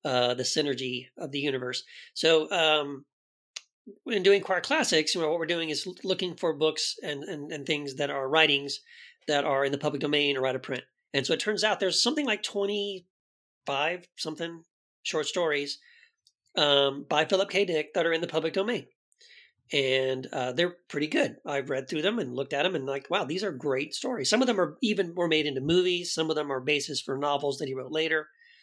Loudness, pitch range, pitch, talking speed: -28 LUFS, 140-180 Hz, 155 Hz, 215 wpm